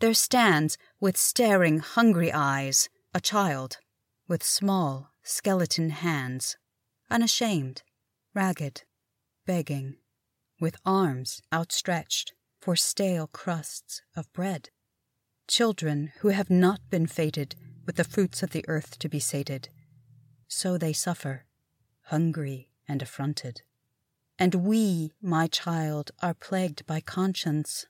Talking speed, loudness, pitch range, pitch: 110 wpm, -27 LUFS, 135-185 Hz, 160 Hz